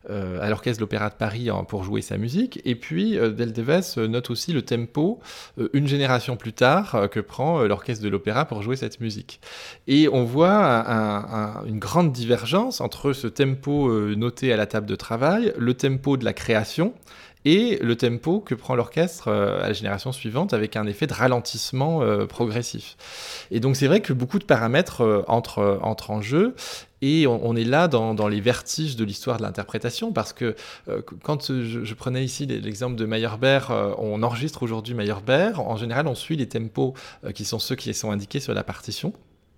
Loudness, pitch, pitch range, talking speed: -23 LUFS, 120 Hz, 110-140 Hz, 185 wpm